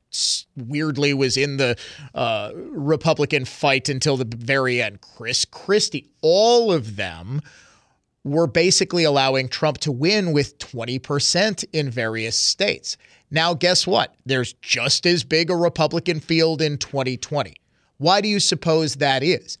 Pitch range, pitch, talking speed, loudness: 130-170 Hz, 145 Hz, 140 wpm, -20 LUFS